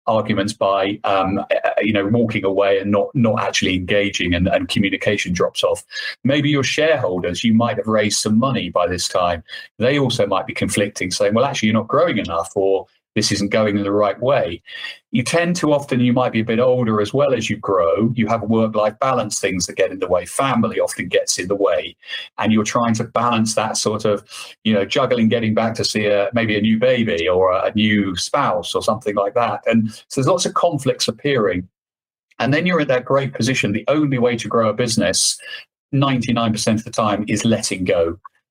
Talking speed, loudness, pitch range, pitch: 215 wpm, -18 LUFS, 105-125 Hz, 110 Hz